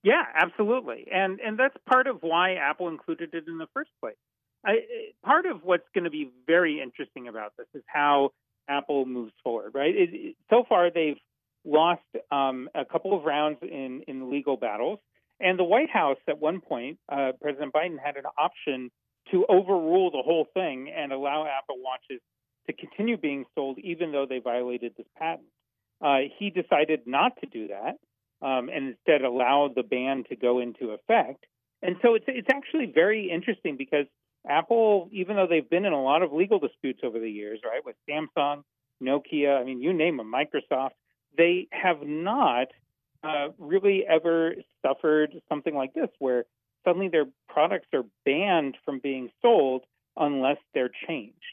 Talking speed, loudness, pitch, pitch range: 175 wpm, -26 LUFS, 150 Hz, 135-185 Hz